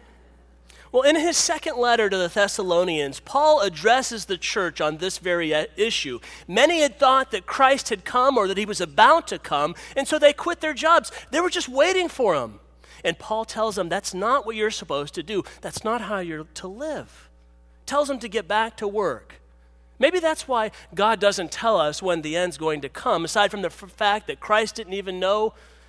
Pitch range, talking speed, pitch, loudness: 175-265 Hz, 205 wpm, 210 Hz, -22 LUFS